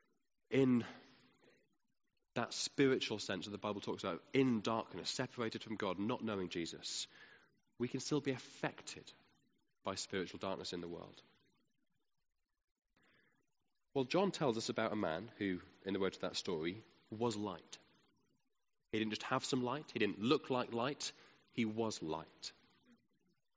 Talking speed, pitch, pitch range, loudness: 150 wpm, 115 Hz, 105-130 Hz, -40 LUFS